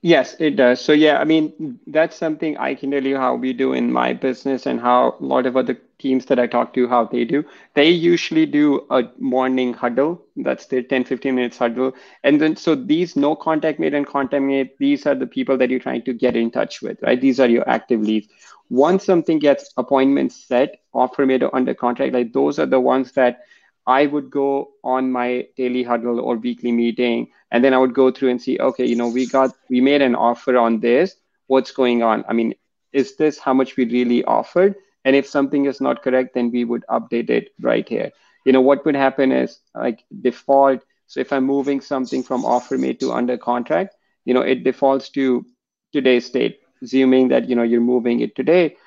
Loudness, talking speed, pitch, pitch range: -18 LUFS, 215 wpm, 130 Hz, 125-140 Hz